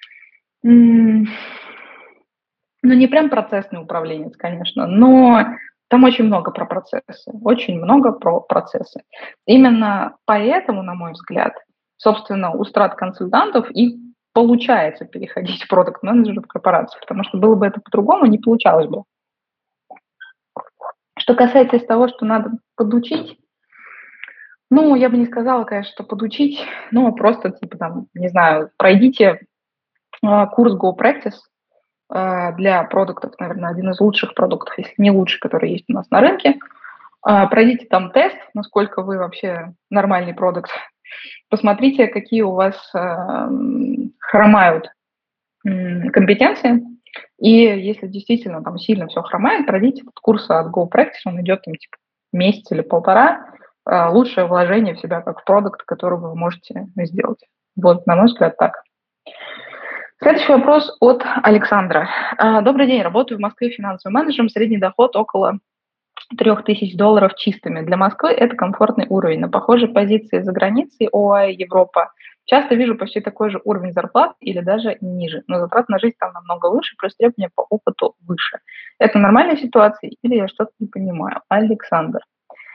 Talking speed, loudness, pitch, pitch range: 135 wpm, -16 LUFS, 215 Hz, 190-240 Hz